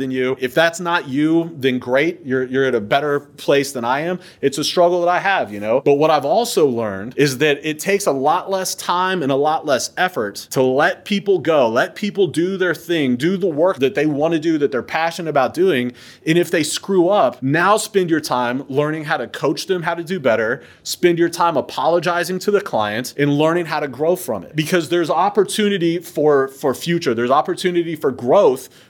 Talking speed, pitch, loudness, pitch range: 220 wpm, 160 Hz, -18 LUFS, 140-180 Hz